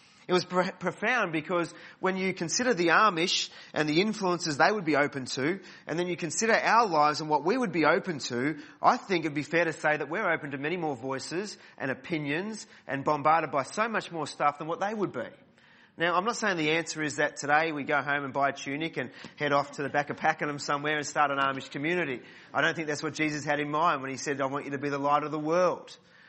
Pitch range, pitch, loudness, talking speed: 145-175 Hz, 155 Hz, -28 LUFS, 250 wpm